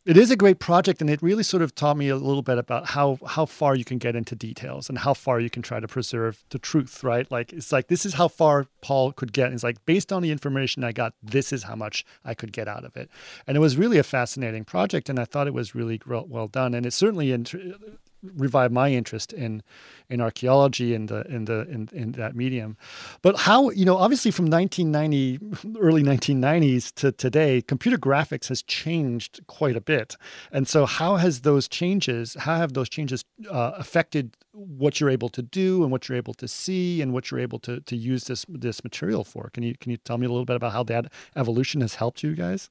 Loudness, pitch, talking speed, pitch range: -24 LUFS, 135 Hz, 235 wpm, 120-160 Hz